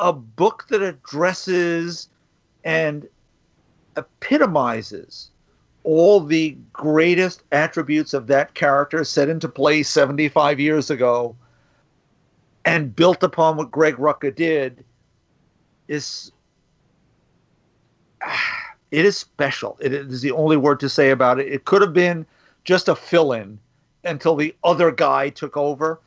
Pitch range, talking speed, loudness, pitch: 140-170 Hz, 125 wpm, -19 LUFS, 155 Hz